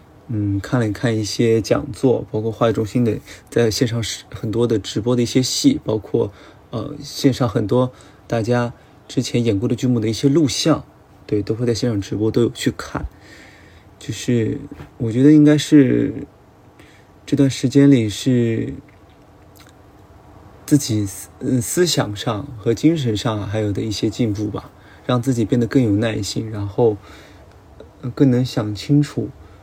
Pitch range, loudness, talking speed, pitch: 105-130 Hz, -19 LUFS, 225 characters per minute, 115 Hz